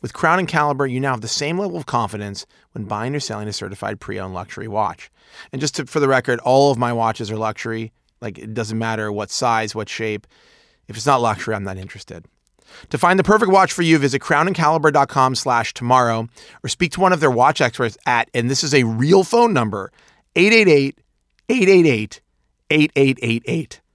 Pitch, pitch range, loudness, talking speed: 125 Hz, 110-150 Hz, -18 LUFS, 190 wpm